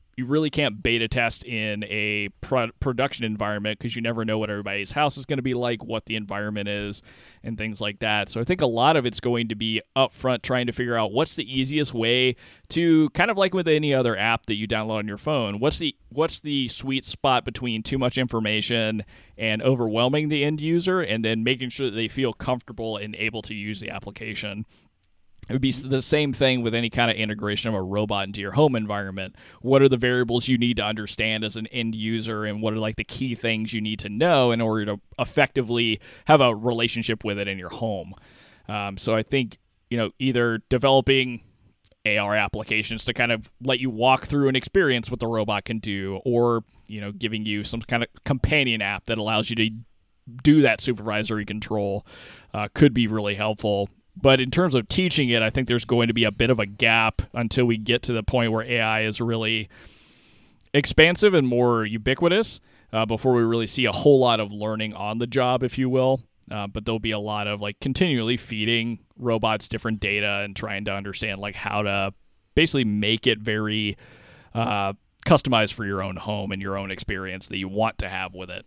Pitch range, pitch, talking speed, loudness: 105-125 Hz, 115 Hz, 215 wpm, -23 LUFS